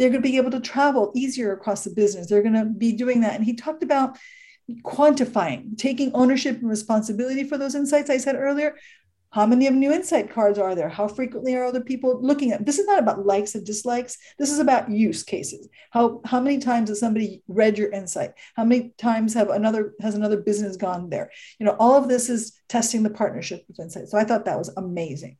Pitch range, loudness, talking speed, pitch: 210-265 Hz, -22 LUFS, 225 wpm, 230 Hz